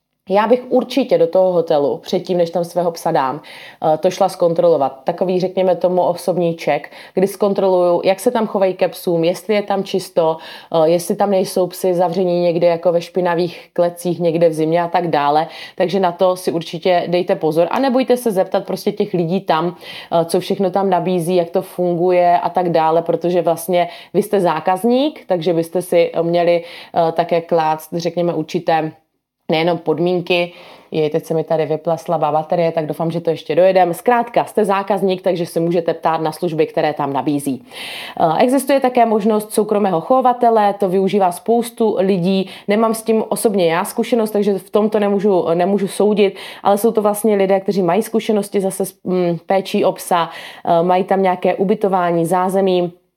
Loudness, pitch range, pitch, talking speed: -17 LUFS, 170-200 Hz, 180 Hz, 170 wpm